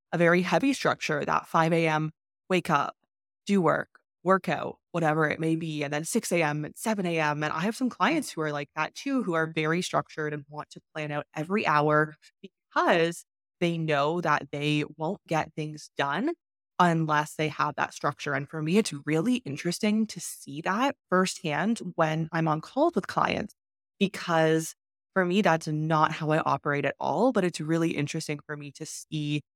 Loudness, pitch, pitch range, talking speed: -27 LUFS, 160 Hz, 150-180 Hz, 185 wpm